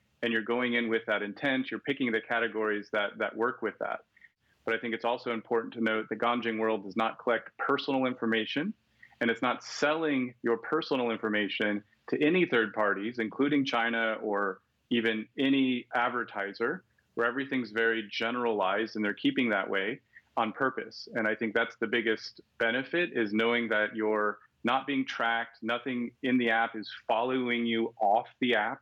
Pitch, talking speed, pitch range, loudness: 115 Hz, 175 wpm, 110-125 Hz, -30 LUFS